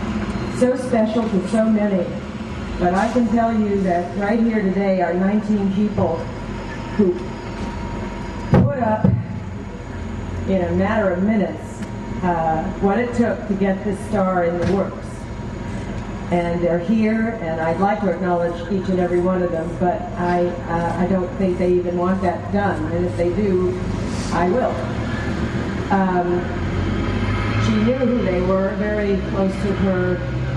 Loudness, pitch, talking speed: -20 LUFS, 180 Hz, 150 wpm